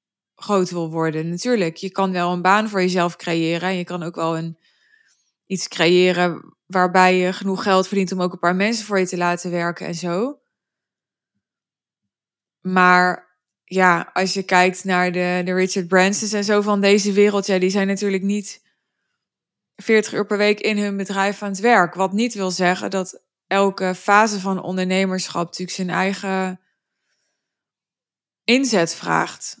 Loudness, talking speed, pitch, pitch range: -19 LUFS, 165 wpm, 190 Hz, 180-200 Hz